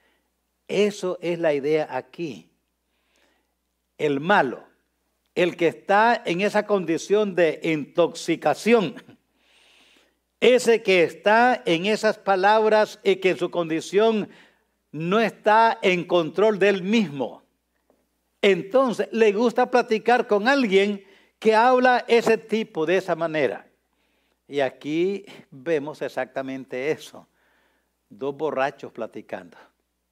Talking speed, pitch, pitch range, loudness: 105 wpm, 195 Hz, 155-215 Hz, -22 LUFS